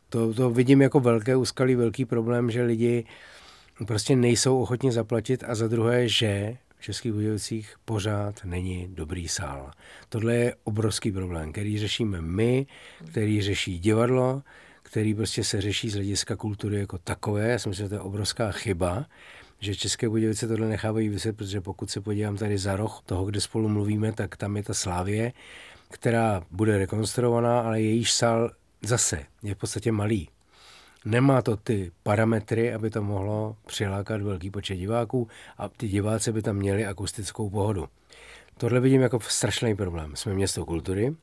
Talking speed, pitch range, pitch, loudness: 165 wpm, 100-115 Hz, 110 Hz, -26 LUFS